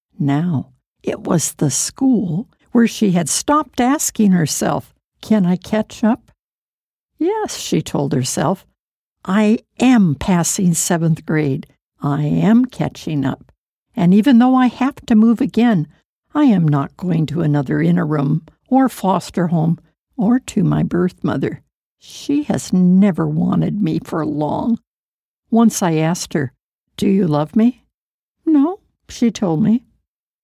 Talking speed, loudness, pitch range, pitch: 140 wpm, -17 LUFS, 155-235 Hz, 185 Hz